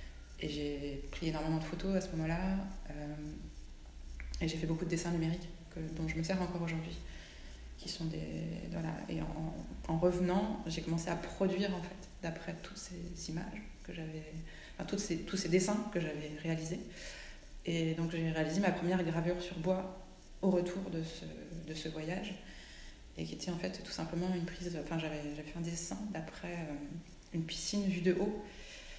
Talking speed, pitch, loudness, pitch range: 190 wpm, 170 Hz, -38 LUFS, 155-185 Hz